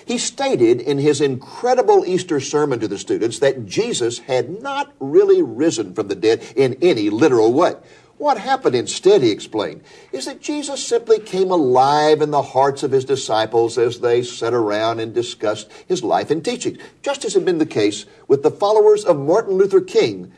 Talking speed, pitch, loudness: 185 wpm, 280 Hz, -18 LUFS